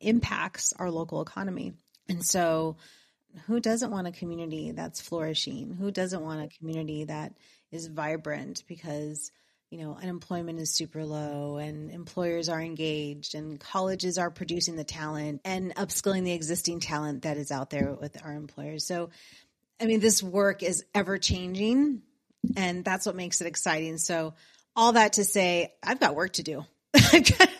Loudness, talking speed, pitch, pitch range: -28 LUFS, 160 wpm, 170 Hz, 155-190 Hz